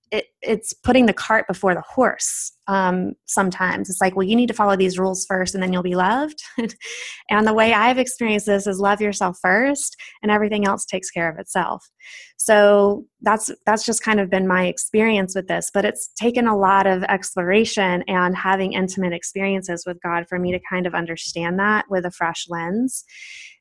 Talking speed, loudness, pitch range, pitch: 195 wpm, -20 LUFS, 185-220 Hz, 200 Hz